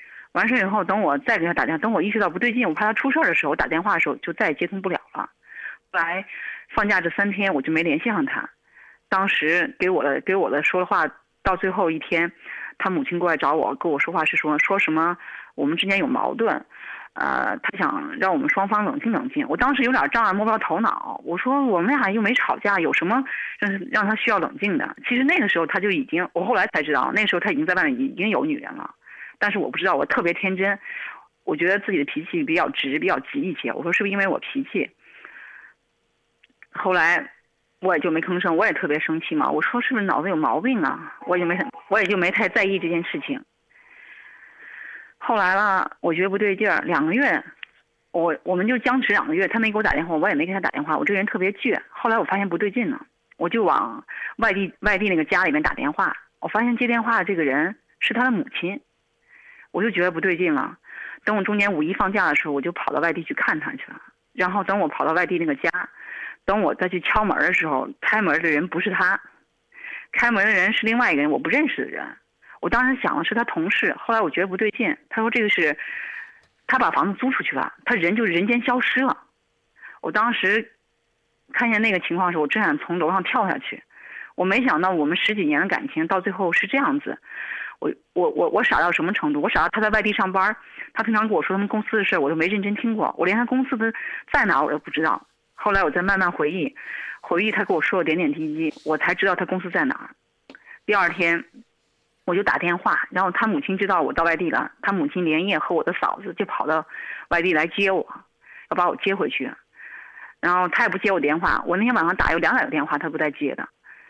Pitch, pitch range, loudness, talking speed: 205 Hz, 180-250 Hz, -22 LUFS, 335 characters per minute